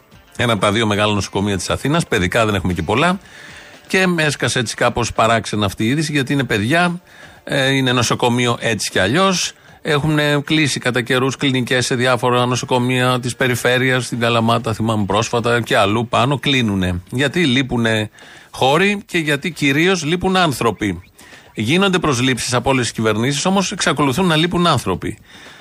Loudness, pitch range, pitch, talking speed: -16 LUFS, 115-150 Hz, 125 Hz, 155 wpm